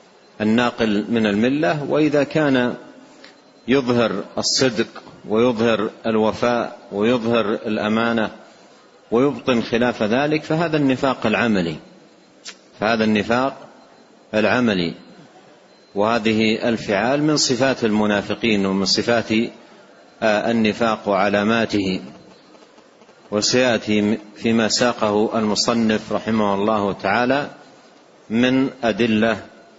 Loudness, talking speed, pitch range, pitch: -19 LUFS, 75 wpm, 105-120 Hz, 115 Hz